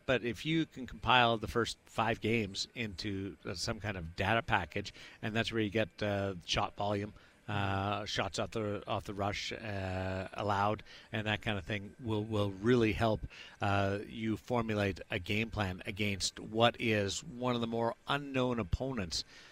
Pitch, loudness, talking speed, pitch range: 105 Hz, -35 LUFS, 170 wpm, 100-115 Hz